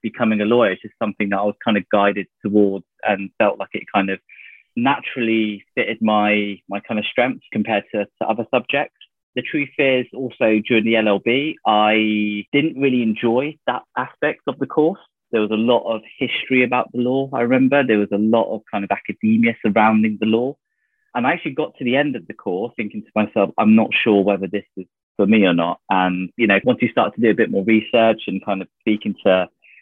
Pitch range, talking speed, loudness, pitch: 100-120 Hz, 220 wpm, -19 LUFS, 110 Hz